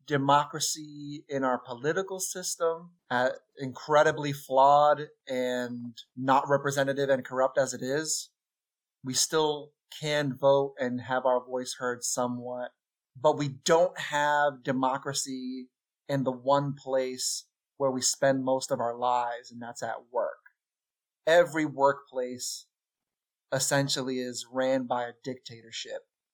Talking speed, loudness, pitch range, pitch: 125 wpm, -28 LUFS, 125-145 Hz, 135 Hz